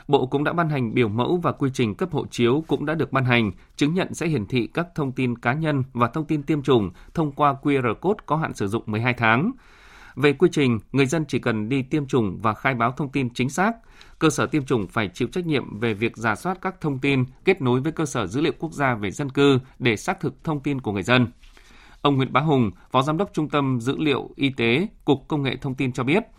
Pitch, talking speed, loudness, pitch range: 140 Hz, 260 wpm, -23 LUFS, 120-155 Hz